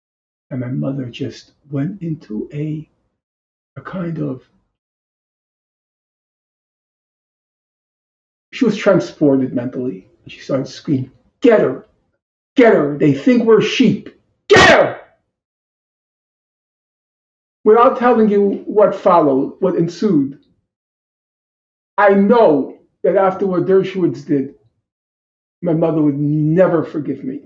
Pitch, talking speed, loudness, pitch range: 155 Hz, 105 wpm, -15 LUFS, 135-200 Hz